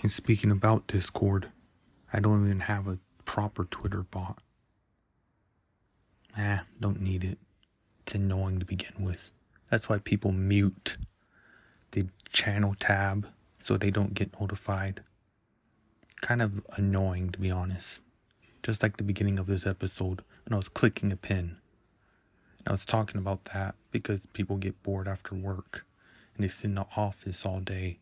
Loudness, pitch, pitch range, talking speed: -31 LUFS, 100 Hz, 95-105 Hz, 155 wpm